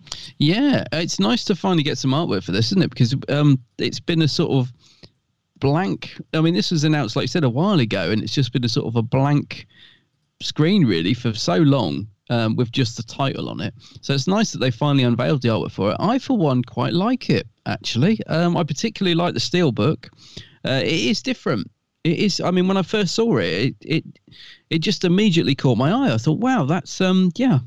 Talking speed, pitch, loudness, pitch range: 225 wpm, 150 Hz, -20 LUFS, 125-180 Hz